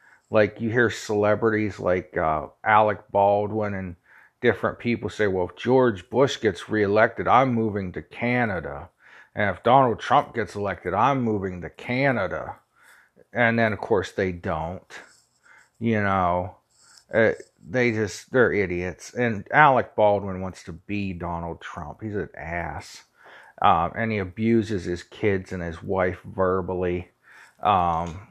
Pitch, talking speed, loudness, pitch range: 105 Hz, 140 wpm, -24 LUFS, 90-115 Hz